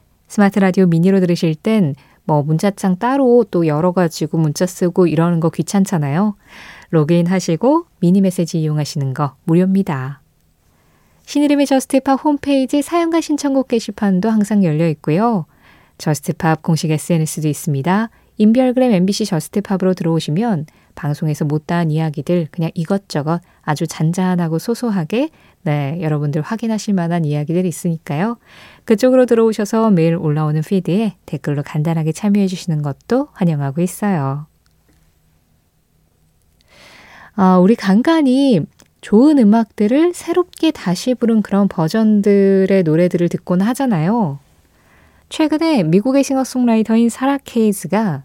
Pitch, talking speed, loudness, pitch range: 185 Hz, 325 characters per minute, -16 LUFS, 160-225 Hz